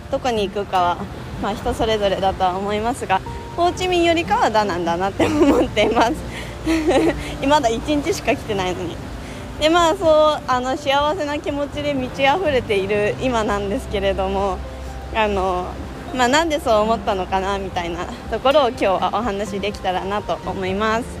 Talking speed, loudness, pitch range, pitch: 350 characters per minute, -20 LUFS, 190-285 Hz, 215 Hz